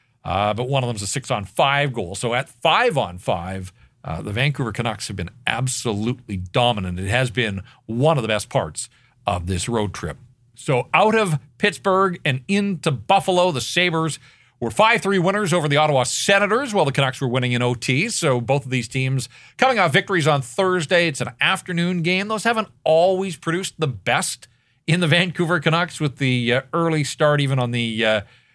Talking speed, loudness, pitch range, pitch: 185 wpm, -20 LUFS, 120-175 Hz, 135 Hz